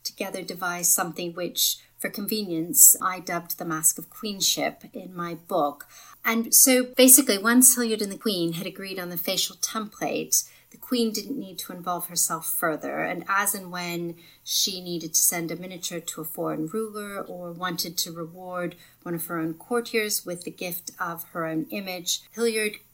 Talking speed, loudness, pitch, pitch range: 180 wpm, -23 LUFS, 180 Hz, 170-210 Hz